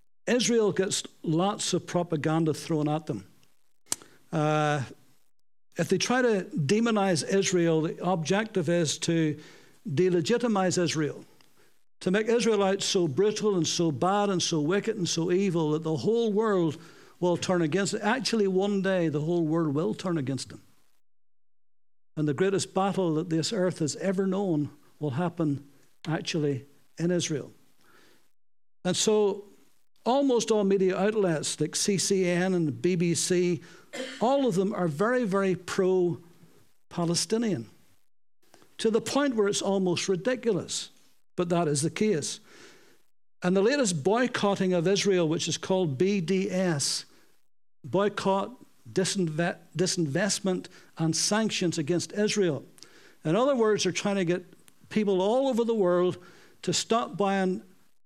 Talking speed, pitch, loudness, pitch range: 135 wpm, 180 Hz, -27 LUFS, 160-200 Hz